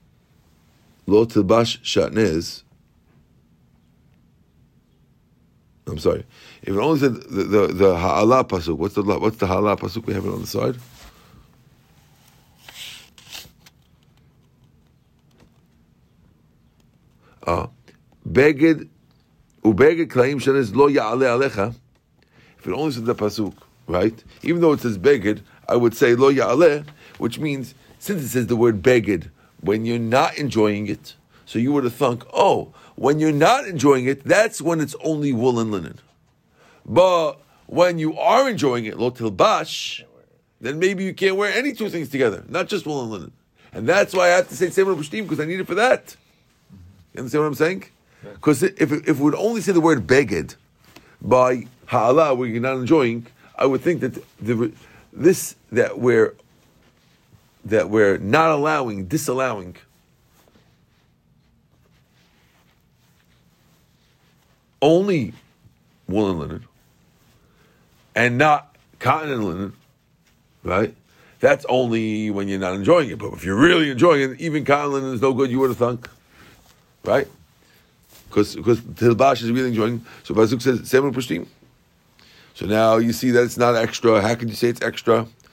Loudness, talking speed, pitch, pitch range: -20 LUFS, 150 wpm, 125 Hz, 110-150 Hz